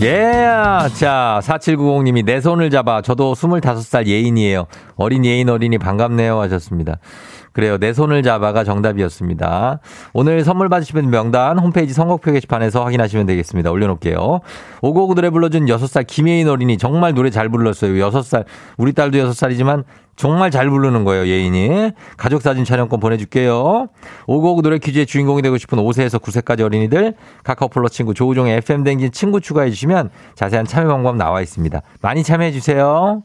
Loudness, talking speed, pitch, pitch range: -15 LUFS, 390 characters per minute, 130 Hz, 110-150 Hz